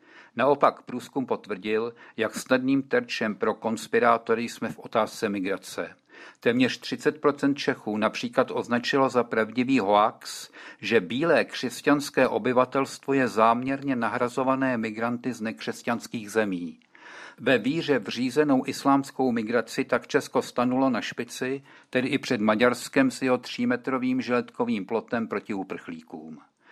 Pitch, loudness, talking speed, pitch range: 130 Hz, -26 LUFS, 115 wpm, 120-135 Hz